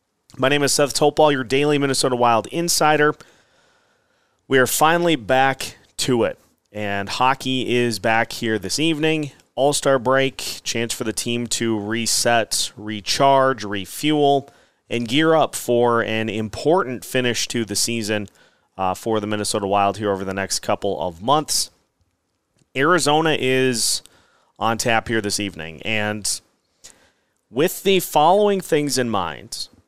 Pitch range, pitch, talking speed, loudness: 105-140 Hz, 120 Hz, 140 wpm, -20 LUFS